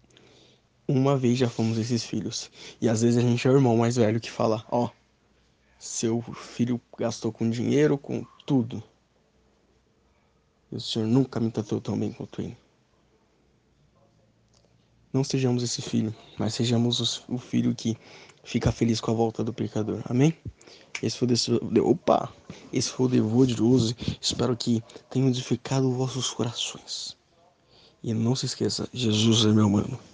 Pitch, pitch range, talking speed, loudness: 115 Hz, 110-125 Hz, 155 wpm, -26 LUFS